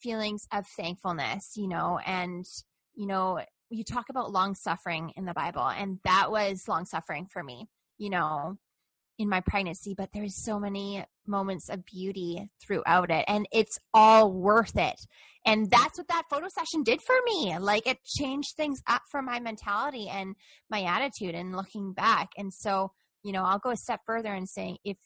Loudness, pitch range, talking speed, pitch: -28 LUFS, 185-225 Hz, 185 wpm, 200 Hz